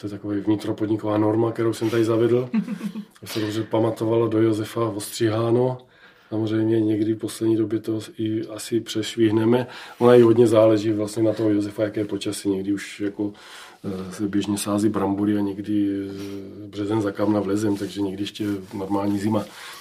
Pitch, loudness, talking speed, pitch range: 110 Hz, -22 LUFS, 165 wpm, 100-115 Hz